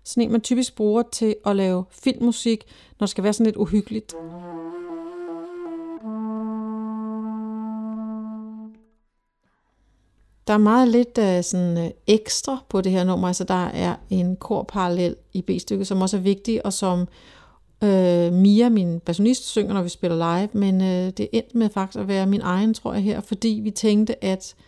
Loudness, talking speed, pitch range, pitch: -22 LUFS, 165 wpm, 190-225 Hz, 215 Hz